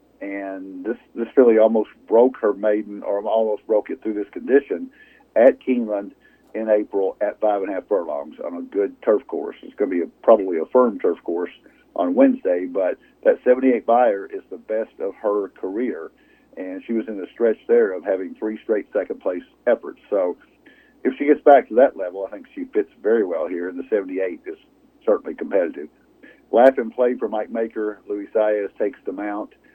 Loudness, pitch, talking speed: -21 LUFS, 115 Hz, 200 wpm